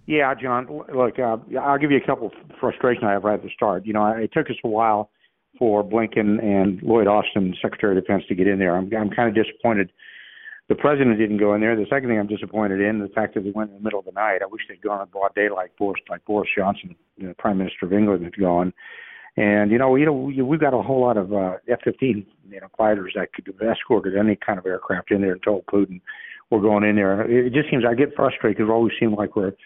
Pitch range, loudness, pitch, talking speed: 100-120 Hz, -21 LUFS, 105 Hz, 275 wpm